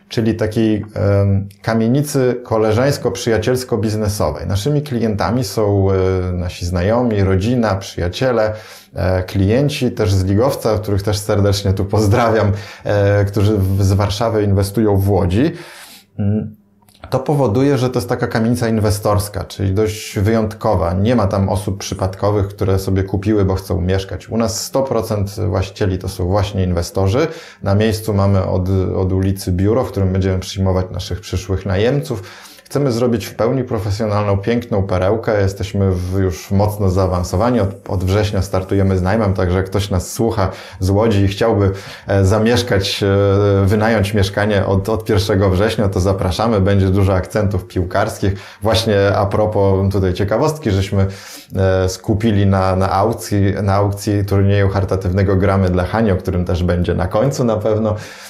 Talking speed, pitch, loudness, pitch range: 140 wpm, 100 Hz, -16 LUFS, 95-110 Hz